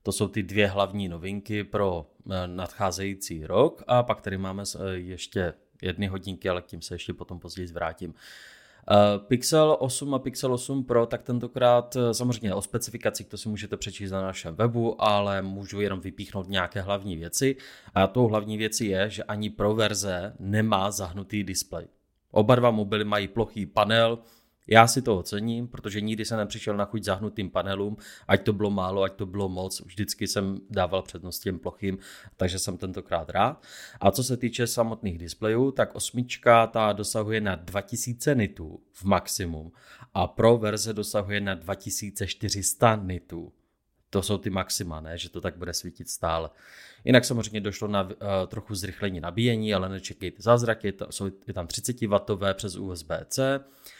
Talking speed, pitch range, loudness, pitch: 165 wpm, 95-110 Hz, -27 LUFS, 100 Hz